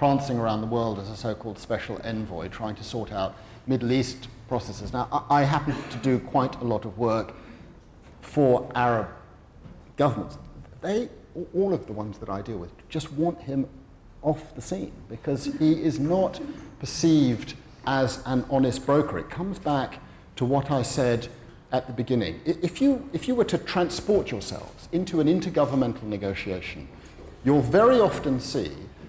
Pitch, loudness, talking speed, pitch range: 130 Hz, -26 LUFS, 165 wpm, 110-150 Hz